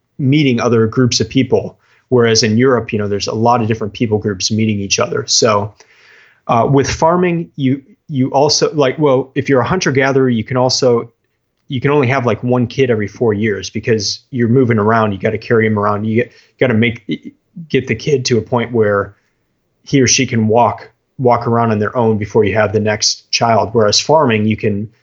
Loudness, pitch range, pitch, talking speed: -14 LUFS, 110-130 Hz, 115 Hz, 215 wpm